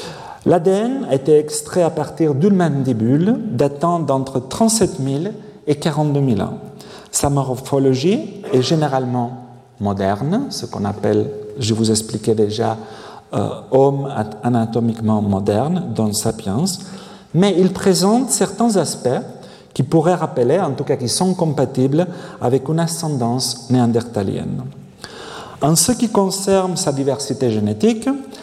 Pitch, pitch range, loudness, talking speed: 140 Hz, 120-180 Hz, -18 LUFS, 125 wpm